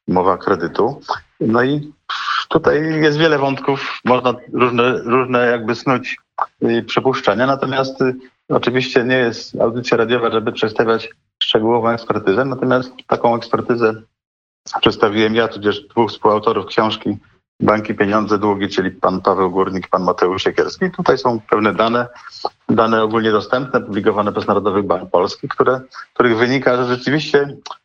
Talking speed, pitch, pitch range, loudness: 130 wpm, 120 Hz, 110-130 Hz, -17 LUFS